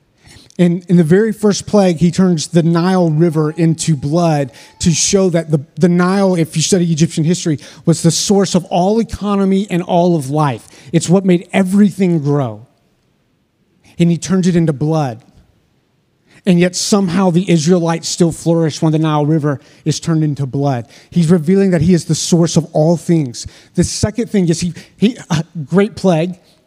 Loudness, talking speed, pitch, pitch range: -14 LUFS, 180 wpm, 170 Hz, 155-185 Hz